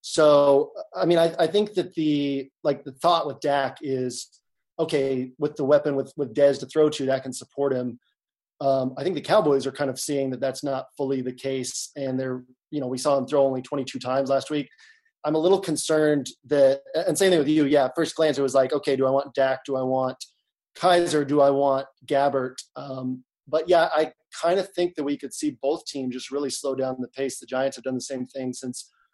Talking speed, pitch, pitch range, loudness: 235 wpm, 140 Hz, 130-150 Hz, -24 LUFS